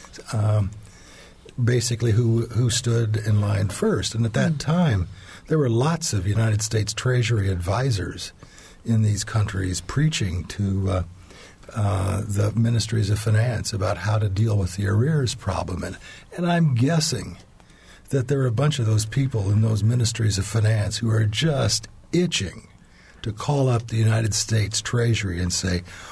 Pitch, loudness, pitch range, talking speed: 110 Hz, -23 LUFS, 100-120 Hz, 160 wpm